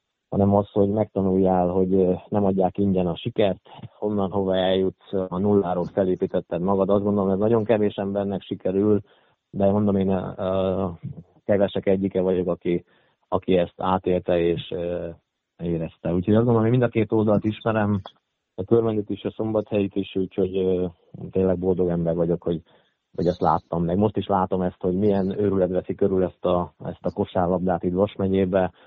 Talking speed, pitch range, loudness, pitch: 170 wpm, 90-100 Hz, -23 LUFS, 95 Hz